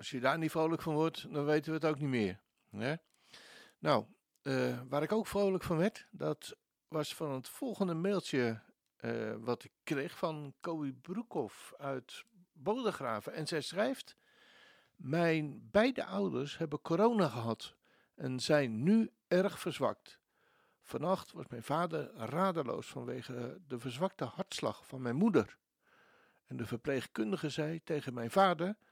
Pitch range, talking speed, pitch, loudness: 130-190 Hz, 145 wpm, 155 Hz, -36 LUFS